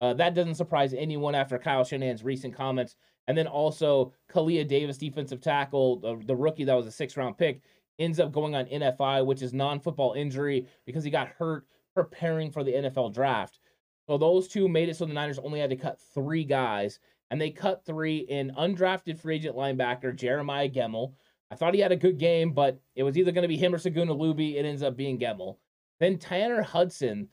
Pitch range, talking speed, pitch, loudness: 135-165 Hz, 205 wpm, 145 Hz, -28 LUFS